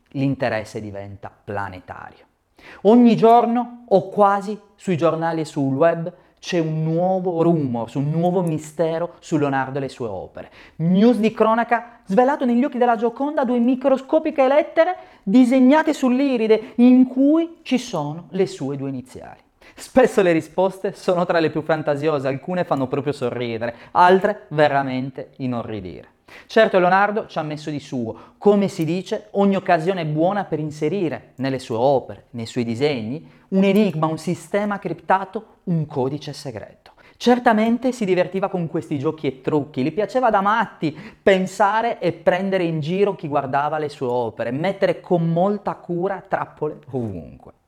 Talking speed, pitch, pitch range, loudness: 150 wpm, 175 Hz, 145-215 Hz, -20 LUFS